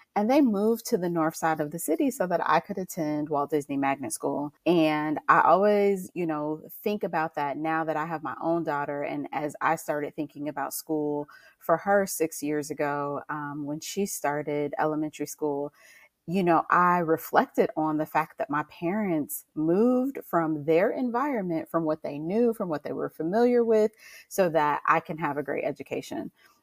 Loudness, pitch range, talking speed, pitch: -27 LUFS, 150-190 Hz, 190 wpm, 160 Hz